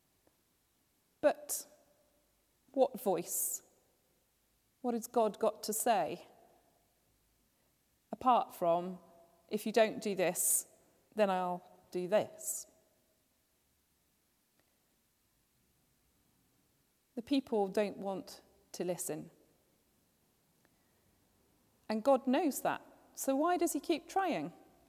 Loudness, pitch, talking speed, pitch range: -34 LUFS, 225 Hz, 85 wpm, 195-275 Hz